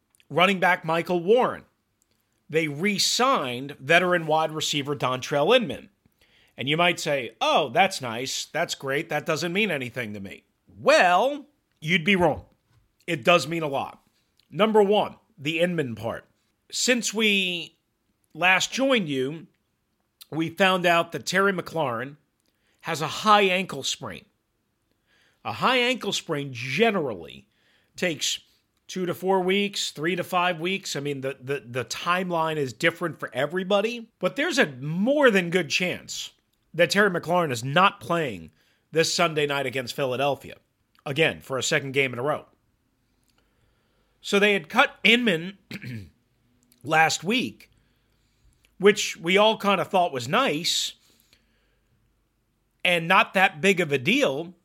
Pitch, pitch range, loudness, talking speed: 165 Hz, 135-195 Hz, -23 LUFS, 140 wpm